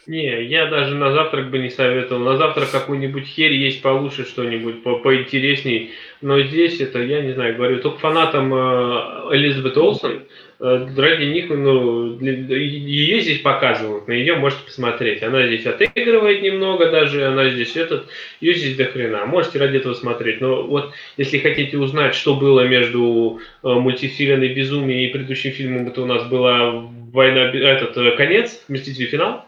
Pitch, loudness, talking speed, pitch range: 135 Hz, -17 LUFS, 165 wpm, 125-145 Hz